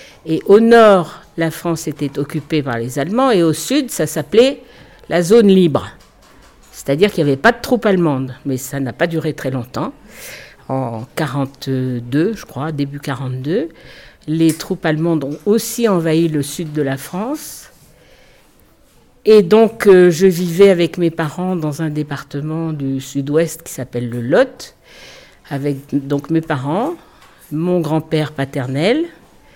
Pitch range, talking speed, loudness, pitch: 140-180 Hz, 150 wpm, -16 LUFS, 155 Hz